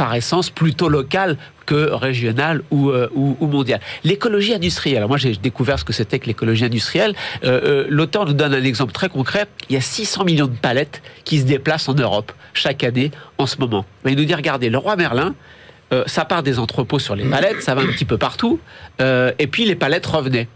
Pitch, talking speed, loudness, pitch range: 140 Hz, 220 wpm, -18 LUFS, 125-160 Hz